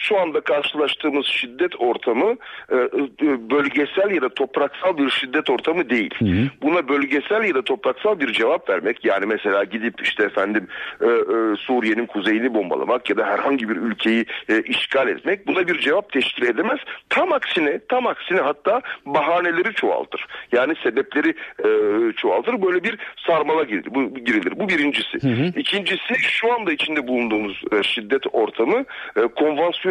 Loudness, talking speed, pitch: -20 LUFS, 130 wpm, 195 Hz